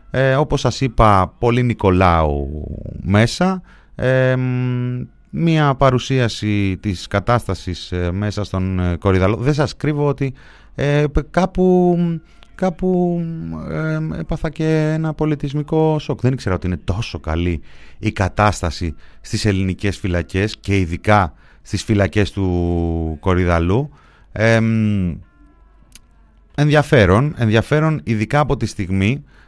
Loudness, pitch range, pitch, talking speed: -18 LUFS, 90-145 Hz, 110 Hz, 110 wpm